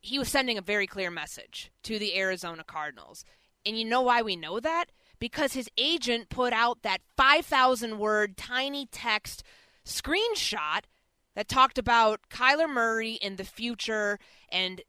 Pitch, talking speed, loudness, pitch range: 235 Hz, 155 wpm, -27 LUFS, 205-260 Hz